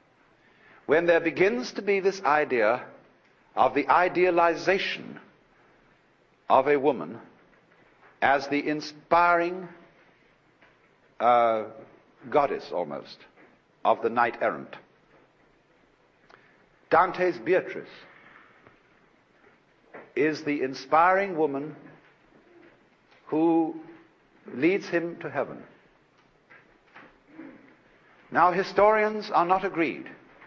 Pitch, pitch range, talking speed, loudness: 170 Hz, 150-185 Hz, 75 wpm, -25 LUFS